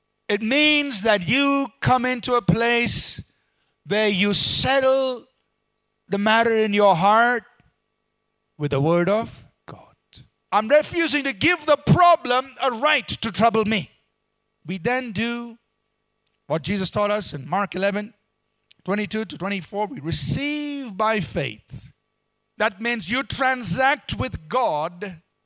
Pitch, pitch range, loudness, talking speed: 220 Hz, 200-260 Hz, -21 LUFS, 130 wpm